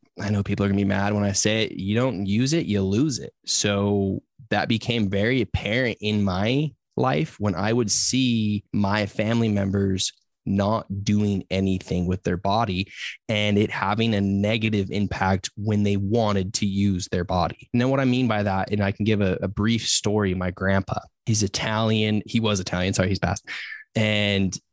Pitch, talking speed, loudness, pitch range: 105 Hz, 190 wpm, -23 LUFS, 100-110 Hz